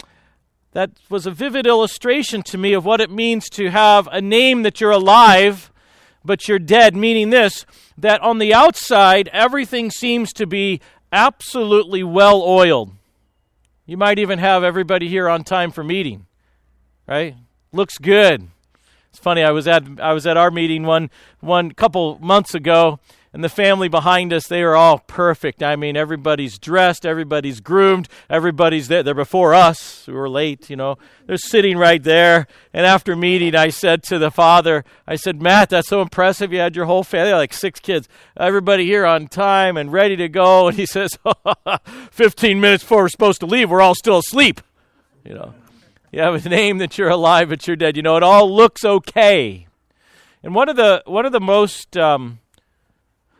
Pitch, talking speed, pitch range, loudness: 180 Hz, 180 wpm, 160-200 Hz, -14 LUFS